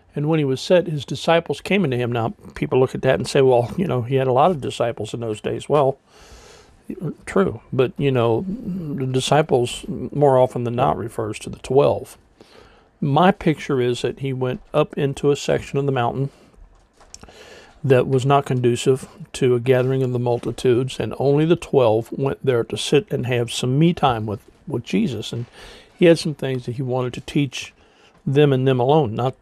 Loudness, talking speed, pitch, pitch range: -20 LUFS, 200 wpm, 130 Hz, 120-145 Hz